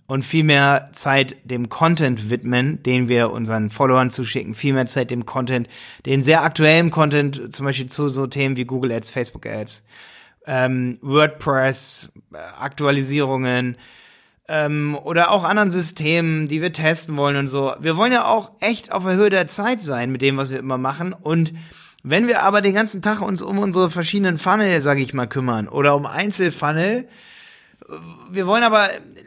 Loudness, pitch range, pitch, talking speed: -19 LUFS, 130-175 Hz, 145 Hz, 175 wpm